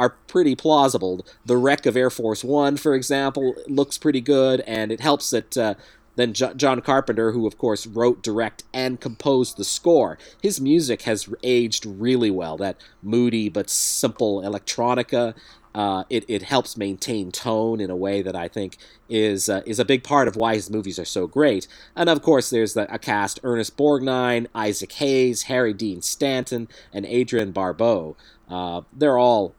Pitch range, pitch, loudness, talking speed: 105-135 Hz, 120 Hz, -22 LUFS, 180 wpm